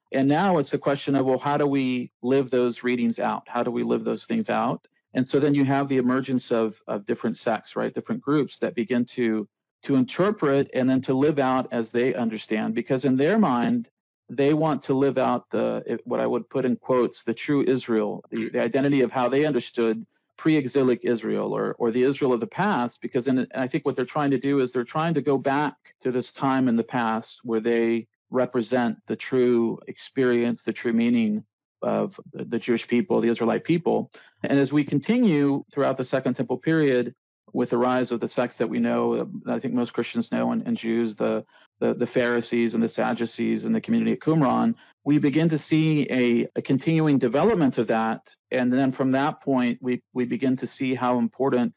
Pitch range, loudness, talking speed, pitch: 120-140 Hz, -24 LUFS, 205 wpm, 130 Hz